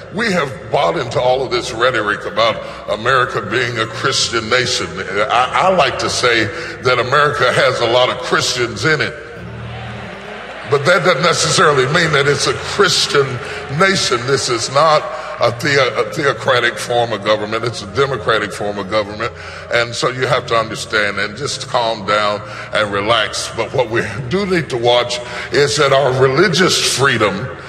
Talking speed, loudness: 170 wpm, -15 LUFS